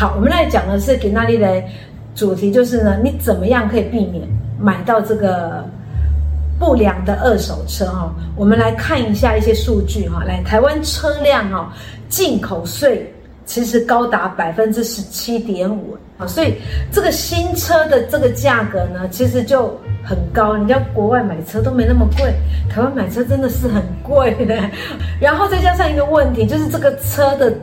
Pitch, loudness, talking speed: 205 Hz, -16 LUFS, 265 characters per minute